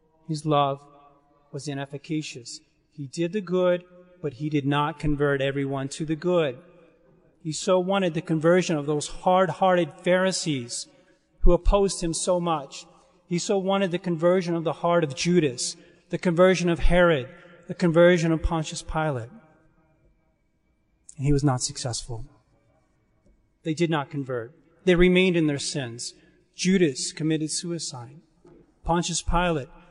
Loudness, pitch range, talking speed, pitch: -24 LUFS, 145-175 Hz, 140 wpm, 165 Hz